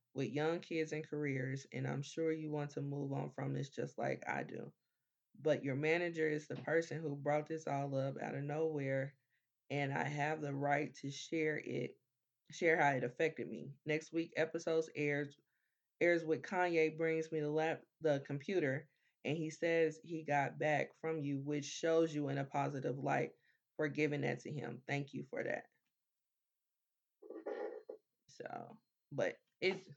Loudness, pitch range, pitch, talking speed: -39 LUFS, 140-160 Hz, 150 Hz, 170 wpm